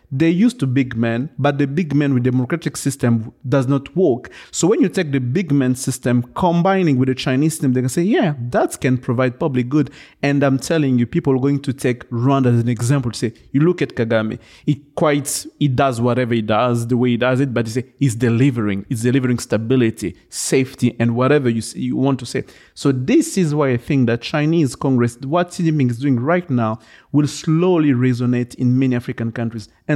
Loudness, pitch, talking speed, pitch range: -18 LUFS, 130 Hz, 215 wpm, 120-145 Hz